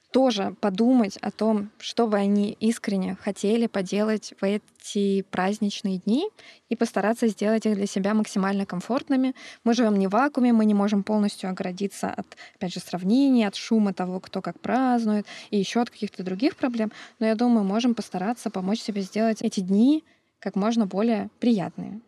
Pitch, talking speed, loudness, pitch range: 215 Hz, 170 wpm, -25 LUFS, 200-235 Hz